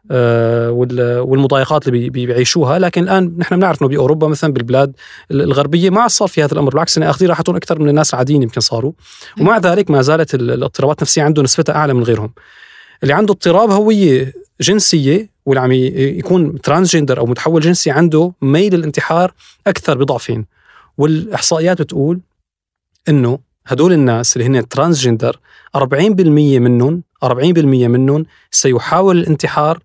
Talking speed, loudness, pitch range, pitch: 140 wpm, -13 LUFS, 130-170 Hz, 150 Hz